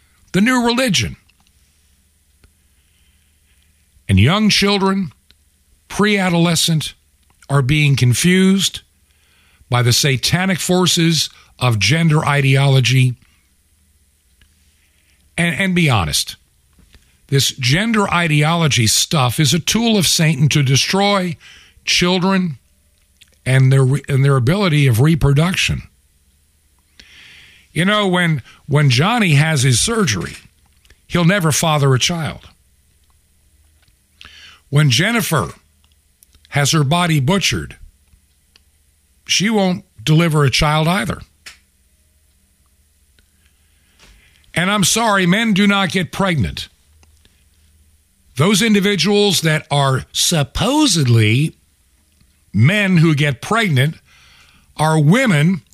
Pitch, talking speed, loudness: 130 Hz, 90 wpm, -15 LUFS